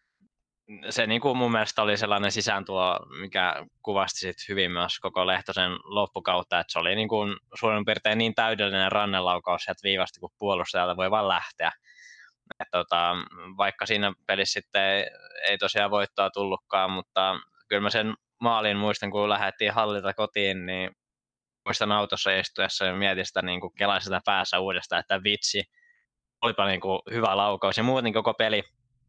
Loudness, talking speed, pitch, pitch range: -26 LUFS, 150 wpm, 100 Hz, 95-110 Hz